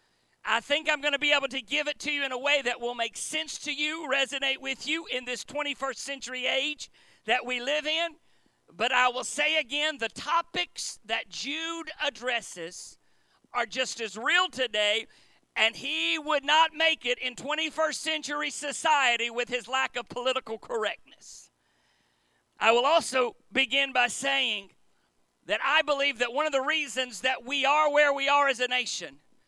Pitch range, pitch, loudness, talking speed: 245-300 Hz, 270 Hz, -27 LUFS, 175 wpm